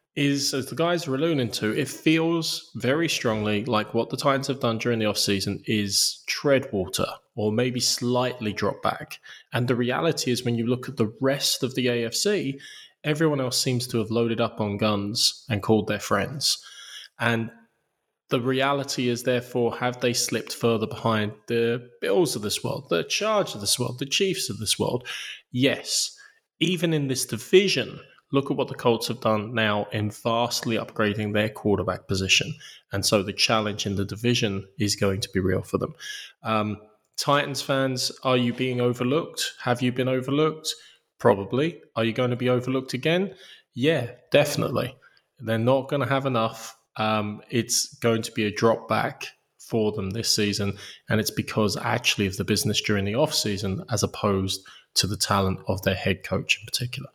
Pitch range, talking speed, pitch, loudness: 105-135 Hz, 180 wpm, 120 Hz, -25 LUFS